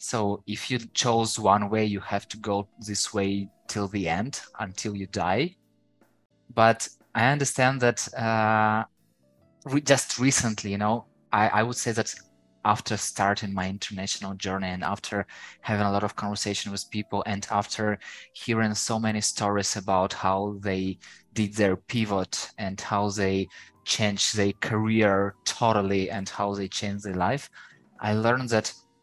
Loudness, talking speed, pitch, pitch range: -26 LUFS, 155 wpm, 105 Hz, 100-110 Hz